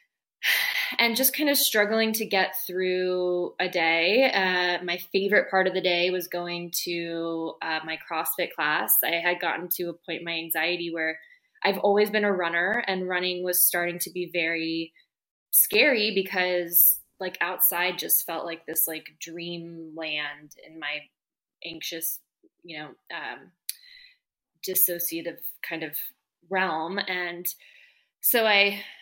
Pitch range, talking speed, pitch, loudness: 170-200 Hz, 145 wpm, 180 Hz, -24 LUFS